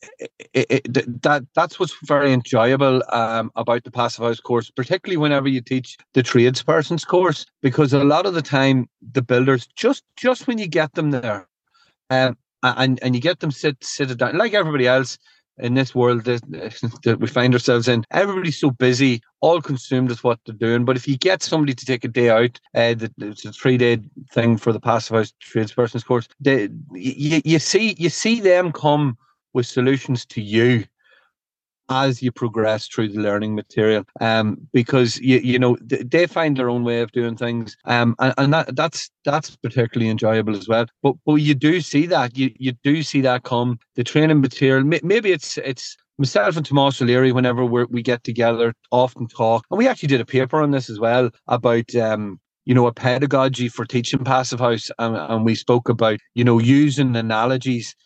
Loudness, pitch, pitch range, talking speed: -19 LUFS, 130 Hz, 120-145 Hz, 195 wpm